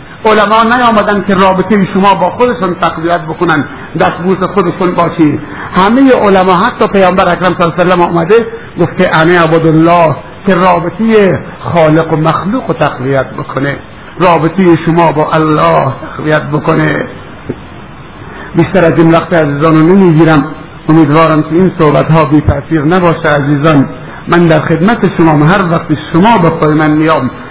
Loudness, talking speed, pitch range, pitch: -8 LUFS, 150 wpm, 155-185 Hz, 165 Hz